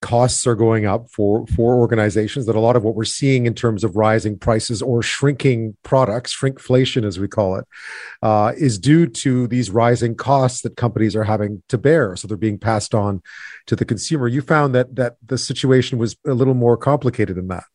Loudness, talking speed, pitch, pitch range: -18 LUFS, 205 wpm, 120 Hz, 110-130 Hz